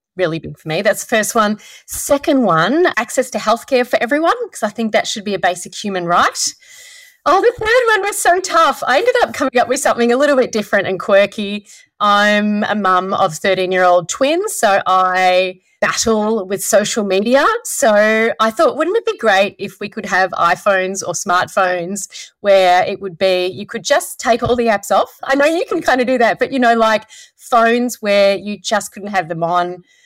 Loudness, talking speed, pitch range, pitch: -15 LUFS, 210 wpm, 190-270 Hz, 215 Hz